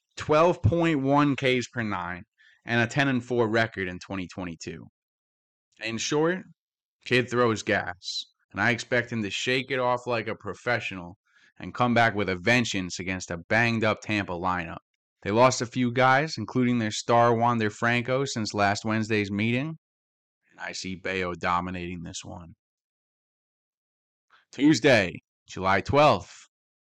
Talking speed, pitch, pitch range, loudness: 150 wpm, 110 Hz, 95-125 Hz, -25 LUFS